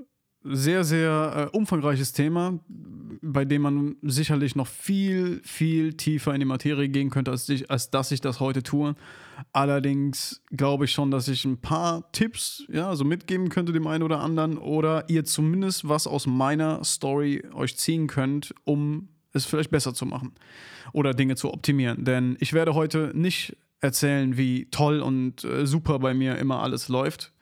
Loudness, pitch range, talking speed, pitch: -25 LUFS, 135-160 Hz, 175 wpm, 145 Hz